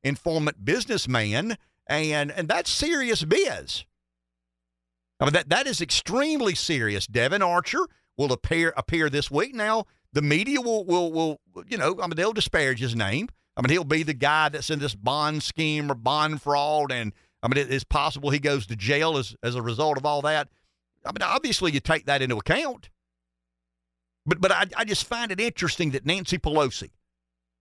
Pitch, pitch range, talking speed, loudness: 150 Hz, 115-170 Hz, 185 wpm, -25 LUFS